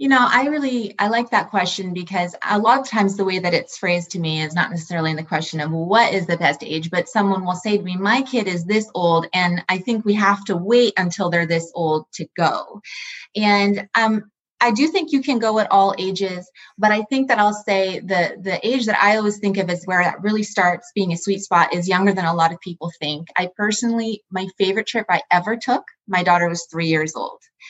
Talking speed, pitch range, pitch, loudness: 245 wpm, 175-215 Hz, 195 Hz, -19 LUFS